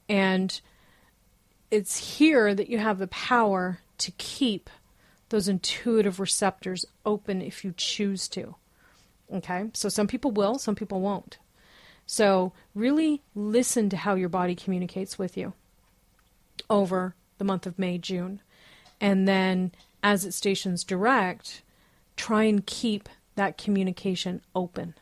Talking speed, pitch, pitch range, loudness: 130 wpm, 195 Hz, 185-210 Hz, -27 LUFS